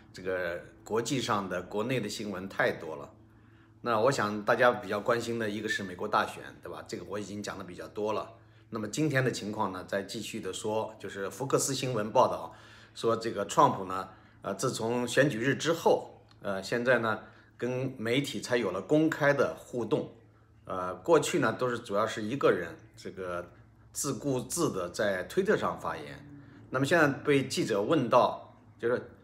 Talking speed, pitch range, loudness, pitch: 265 characters per minute, 105-125 Hz, -30 LUFS, 110 Hz